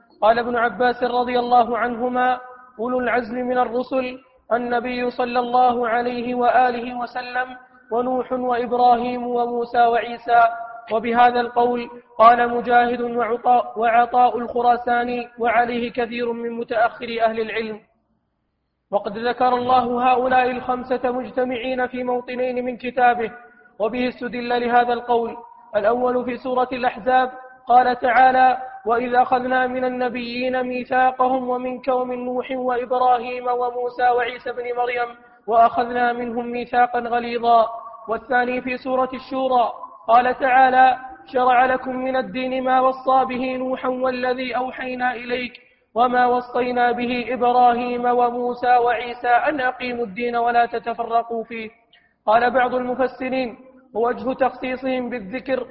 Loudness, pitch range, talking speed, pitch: -20 LUFS, 240-255 Hz, 110 wpm, 245 Hz